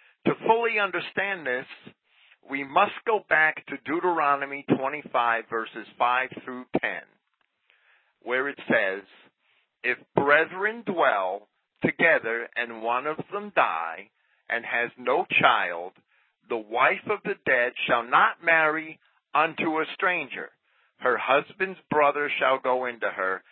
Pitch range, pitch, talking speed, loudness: 125-180 Hz, 145 Hz, 125 wpm, -25 LUFS